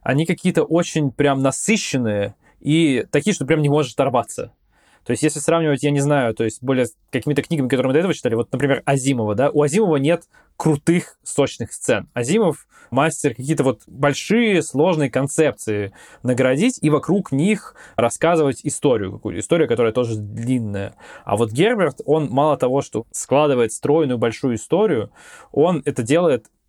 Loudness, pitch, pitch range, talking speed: -19 LUFS, 145 Hz, 130-160 Hz, 160 wpm